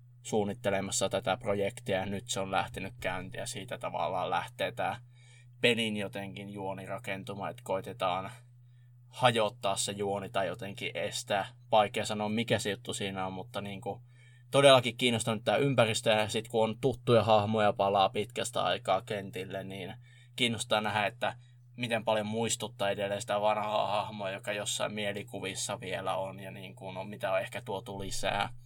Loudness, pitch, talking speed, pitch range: -31 LUFS, 105 Hz, 155 wpm, 100-120 Hz